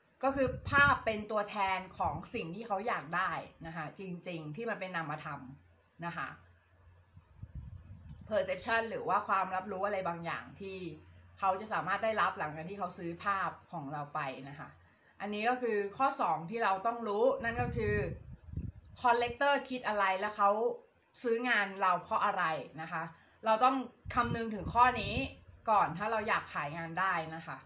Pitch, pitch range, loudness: 190 Hz, 160-230 Hz, -34 LUFS